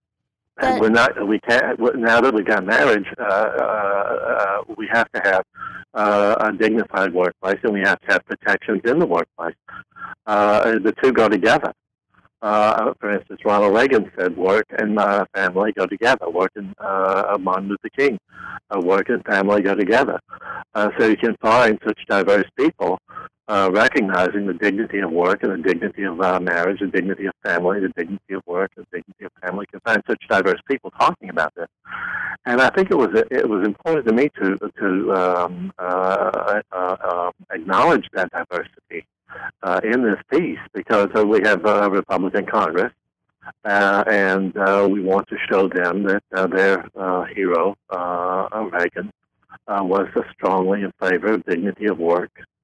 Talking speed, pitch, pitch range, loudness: 175 wpm, 95 Hz, 95-105 Hz, -19 LUFS